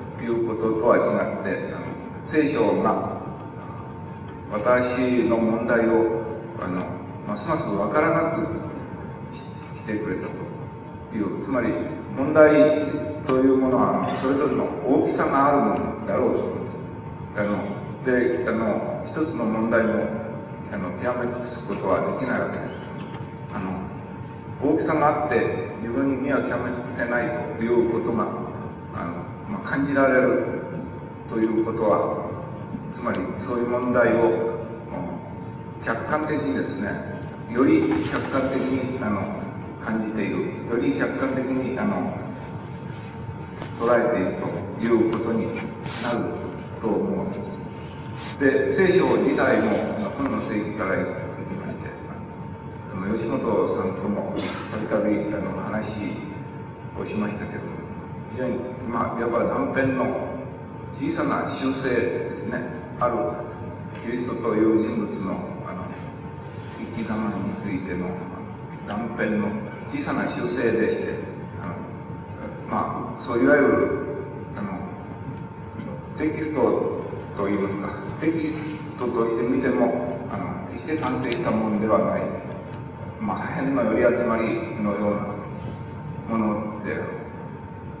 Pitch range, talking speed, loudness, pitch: 110-135 Hz, 235 characters per minute, -25 LUFS, 115 Hz